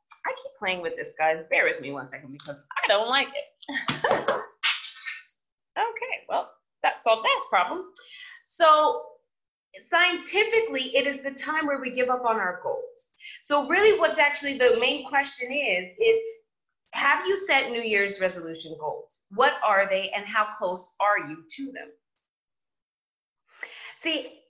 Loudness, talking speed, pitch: -24 LUFS, 150 wpm, 280 Hz